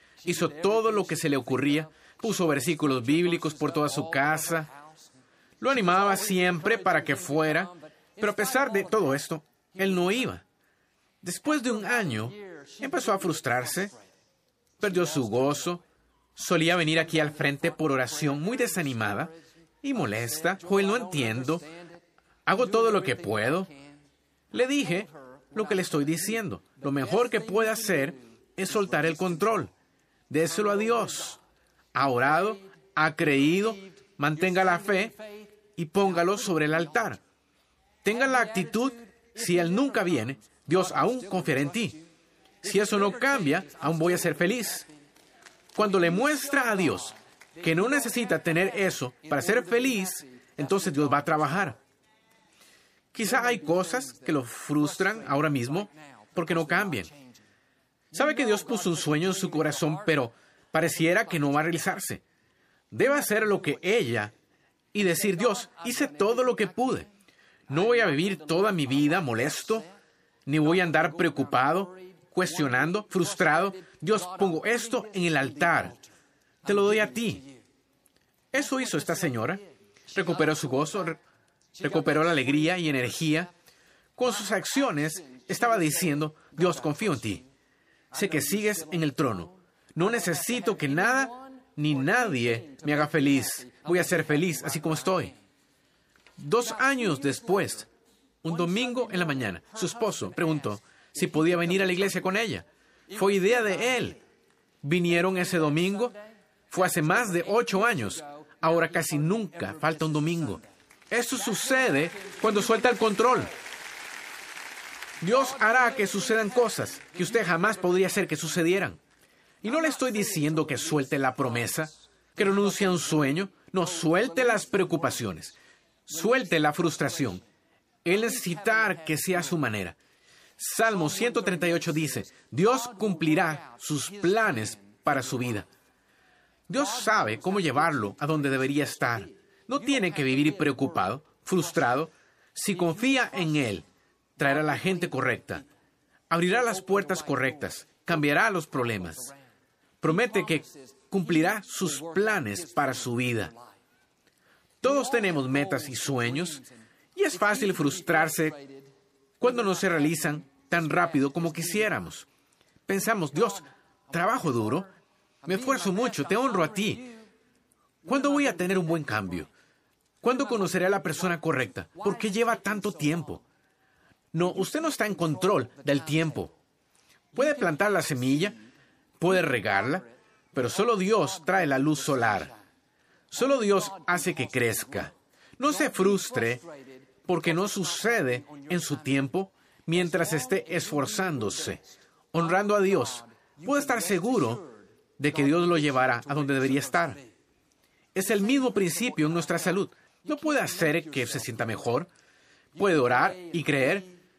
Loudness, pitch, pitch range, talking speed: -27 LUFS, 170 Hz, 145-205 Hz, 145 wpm